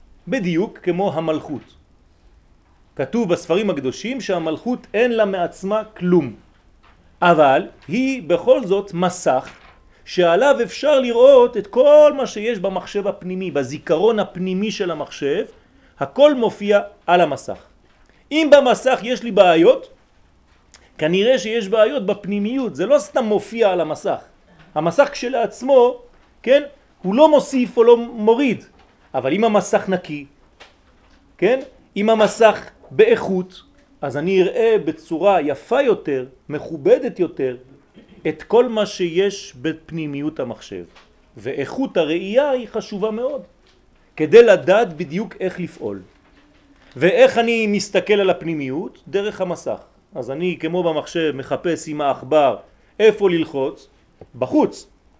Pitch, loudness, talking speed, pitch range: 200 Hz, -18 LUFS, 115 wpm, 165-240 Hz